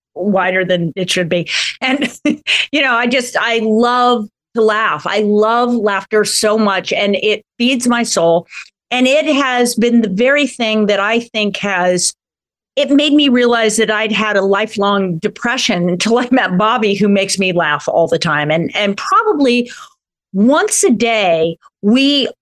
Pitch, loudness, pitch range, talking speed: 215 Hz, -13 LUFS, 195-245 Hz, 170 wpm